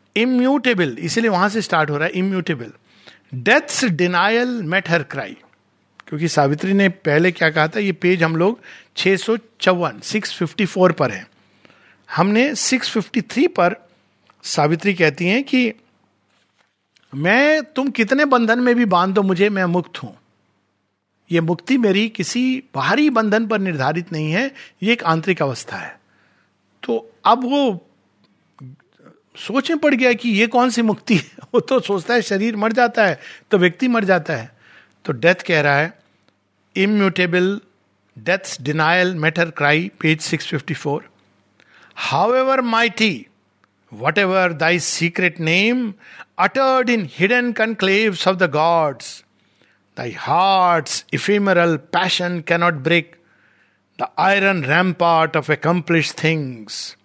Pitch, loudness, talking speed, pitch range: 185 Hz, -18 LUFS, 135 wpm, 160-225 Hz